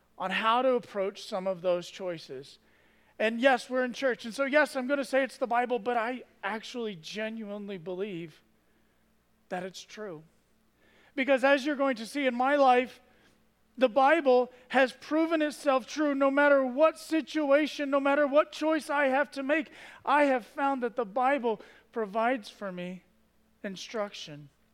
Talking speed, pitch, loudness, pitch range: 165 wpm, 255 Hz, -28 LUFS, 215-280 Hz